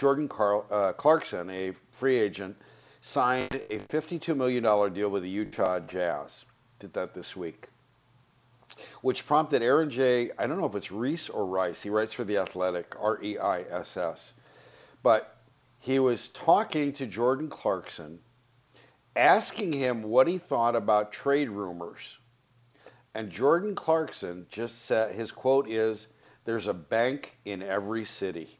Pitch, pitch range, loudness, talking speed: 115 Hz, 105-135 Hz, -28 LUFS, 150 wpm